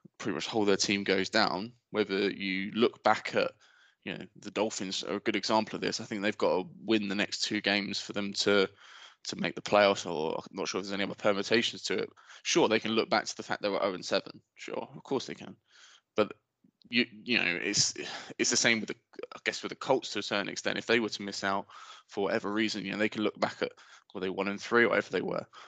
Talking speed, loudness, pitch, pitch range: 260 wpm, -30 LUFS, 100 Hz, 100-110 Hz